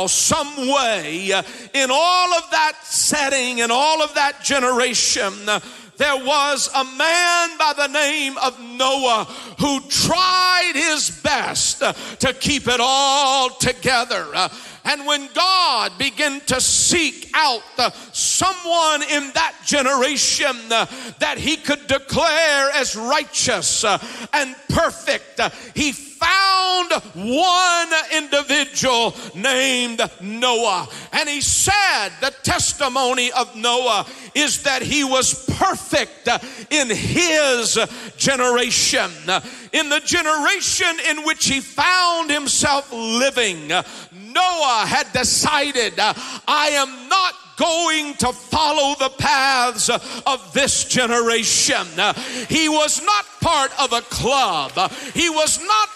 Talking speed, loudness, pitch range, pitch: 110 wpm, -17 LUFS, 250-310 Hz, 280 Hz